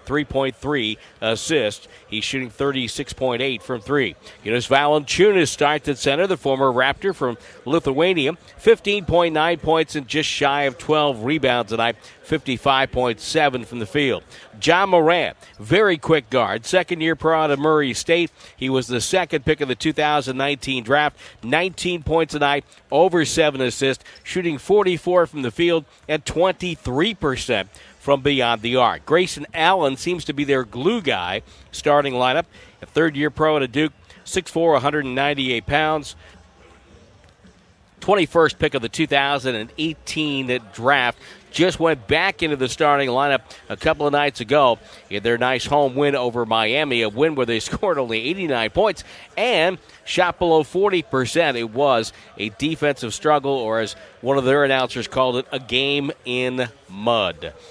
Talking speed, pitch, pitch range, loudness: 150 wpm, 145 Hz, 125-160 Hz, -20 LUFS